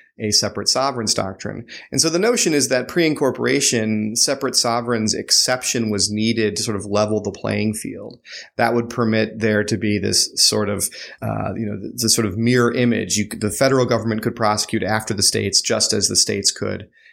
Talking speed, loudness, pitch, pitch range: 195 wpm, -18 LUFS, 110 Hz, 105-125 Hz